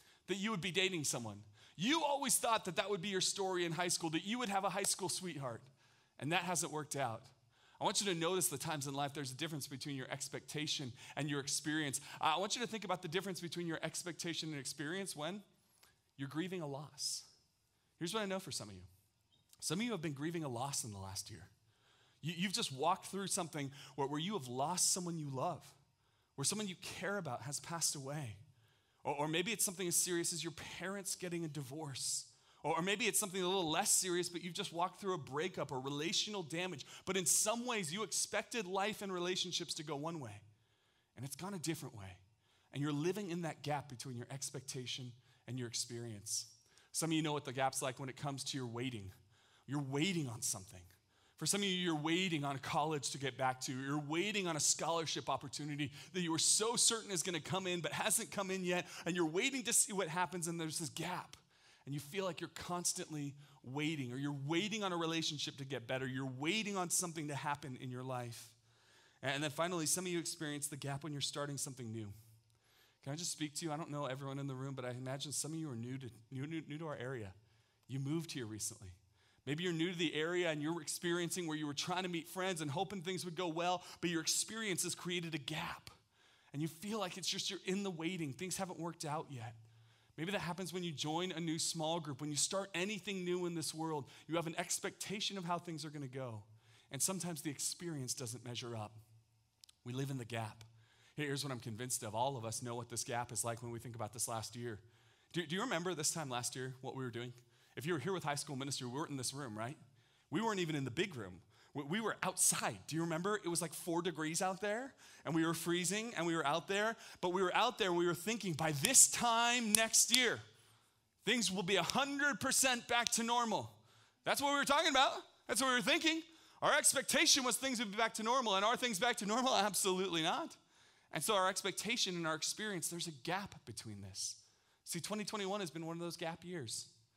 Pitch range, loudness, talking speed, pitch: 130-185 Hz, -38 LUFS, 235 wpm, 160 Hz